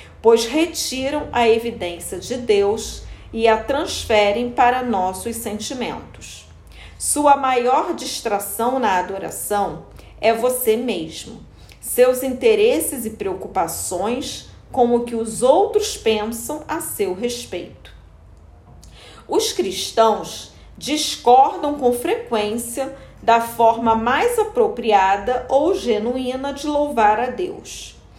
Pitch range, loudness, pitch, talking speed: 225-290 Hz, -19 LUFS, 245 Hz, 100 wpm